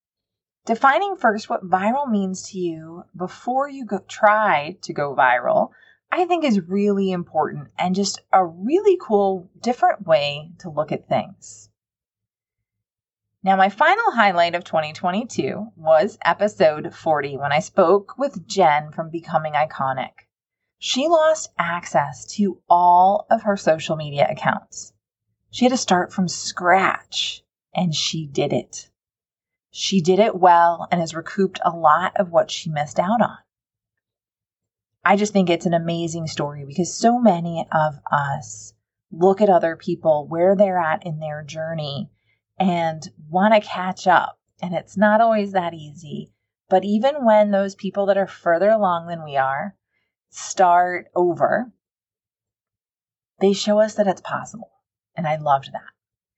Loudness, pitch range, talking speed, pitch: -20 LUFS, 150-200 Hz, 150 wpm, 175 Hz